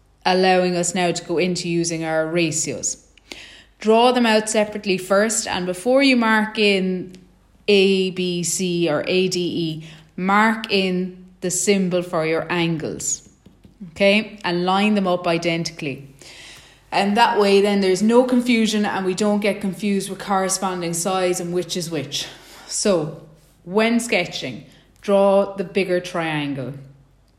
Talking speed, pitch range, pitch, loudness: 135 wpm, 170-200 Hz, 185 Hz, -20 LUFS